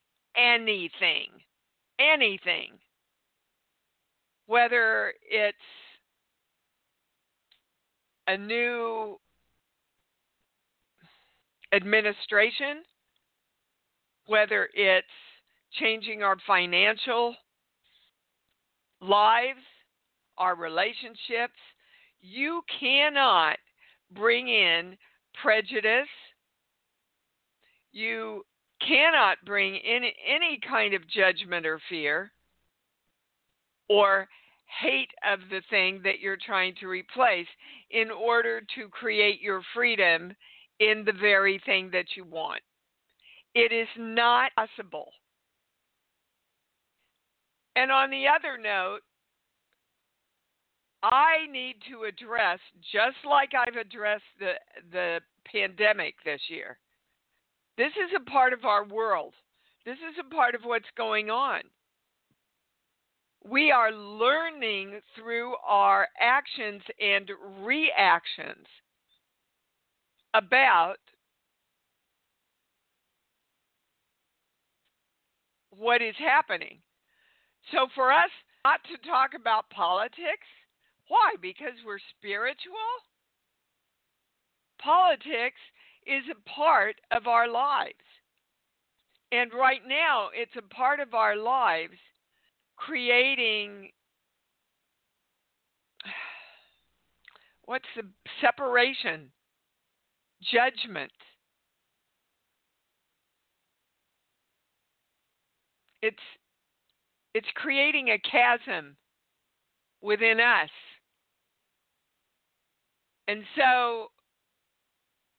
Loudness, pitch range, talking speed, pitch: -25 LUFS, 200-260 Hz, 75 wpm, 225 Hz